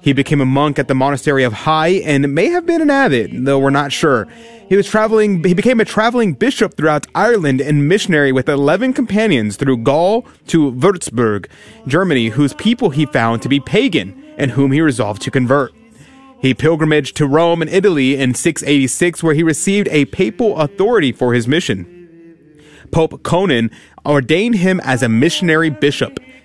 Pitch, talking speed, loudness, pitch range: 155 Hz, 175 wpm, -14 LUFS, 140-195 Hz